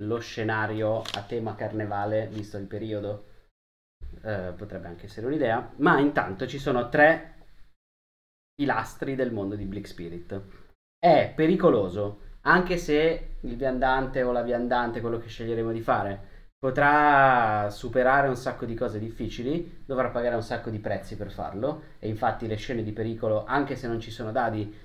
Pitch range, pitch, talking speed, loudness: 105-130 Hz, 110 Hz, 155 wpm, -26 LUFS